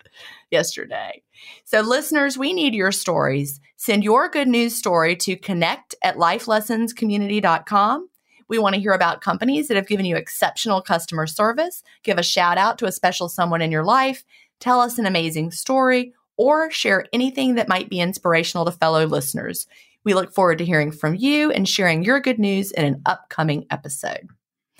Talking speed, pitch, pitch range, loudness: 170 wpm, 200 Hz, 170-250 Hz, -20 LUFS